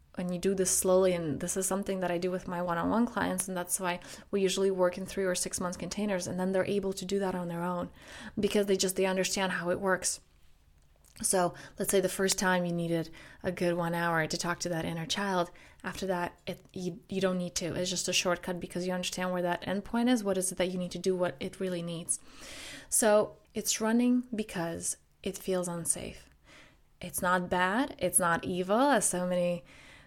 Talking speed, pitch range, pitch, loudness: 225 wpm, 175-190 Hz, 180 Hz, -31 LUFS